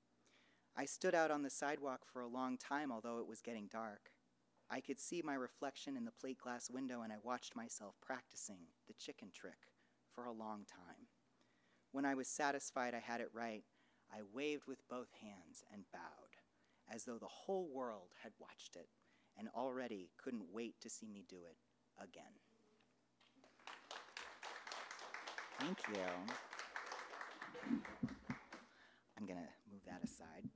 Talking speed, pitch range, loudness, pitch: 155 wpm, 100-135 Hz, -48 LUFS, 120 Hz